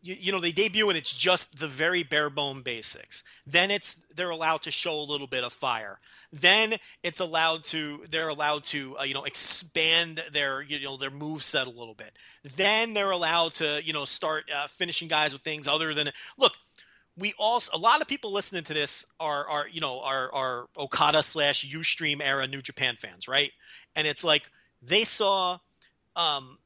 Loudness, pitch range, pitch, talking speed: -26 LUFS, 140-175 Hz, 155 Hz, 195 wpm